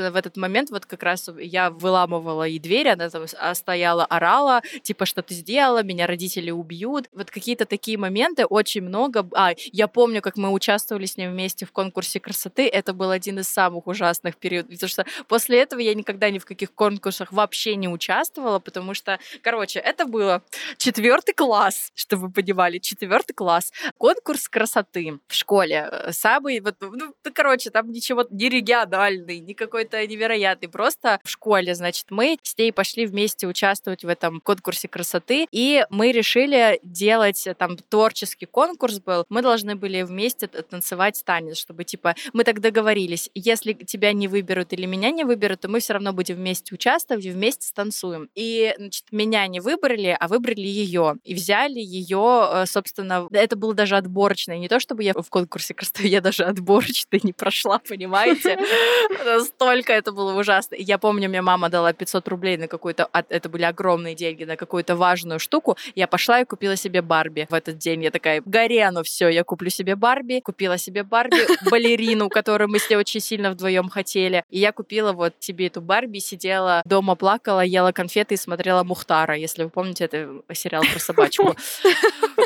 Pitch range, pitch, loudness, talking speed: 180-225 Hz, 195 Hz, -21 LUFS, 175 wpm